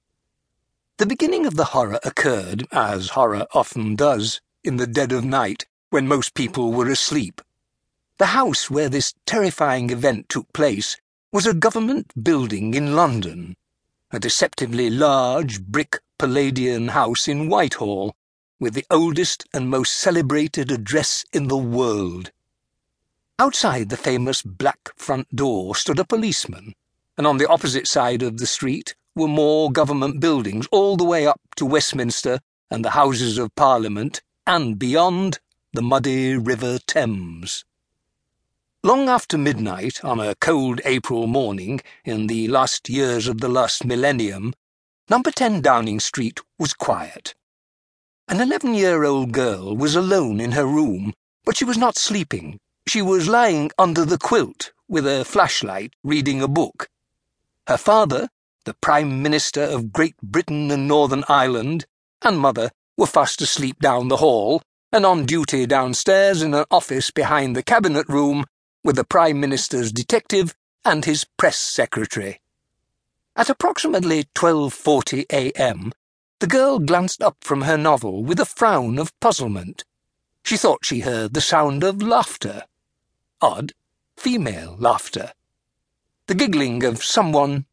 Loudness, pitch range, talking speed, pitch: -20 LUFS, 120-160 Hz, 145 wpm, 140 Hz